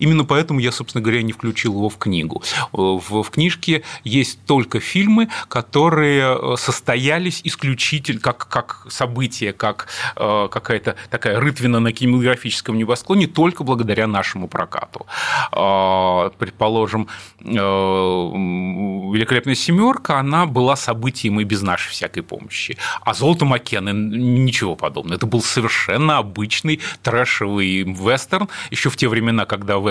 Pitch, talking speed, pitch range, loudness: 120 Hz, 130 wpm, 105-145 Hz, -18 LUFS